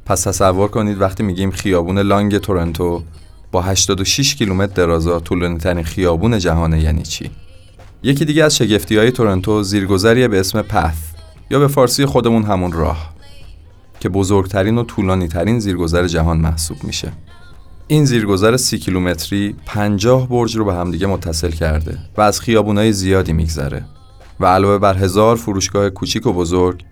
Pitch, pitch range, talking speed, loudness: 95 Hz, 85-105 Hz, 150 wpm, -15 LUFS